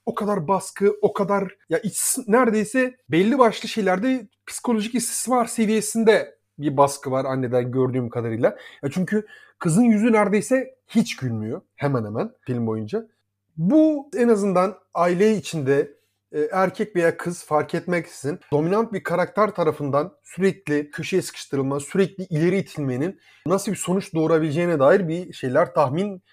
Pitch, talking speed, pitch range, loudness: 185 Hz, 135 wpm, 150-215 Hz, -22 LUFS